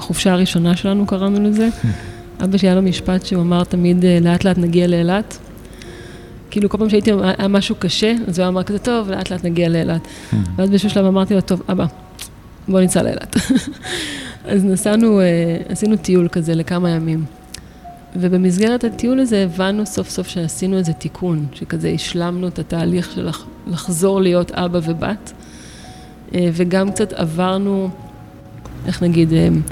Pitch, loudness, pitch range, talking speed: 185 Hz, -17 LUFS, 170-195 Hz, 145 wpm